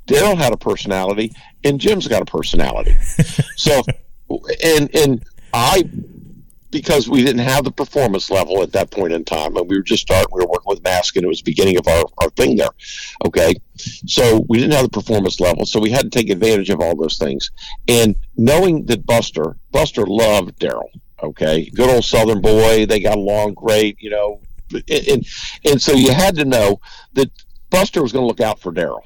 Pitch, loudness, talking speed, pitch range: 115 Hz, -16 LUFS, 200 wpm, 105-150 Hz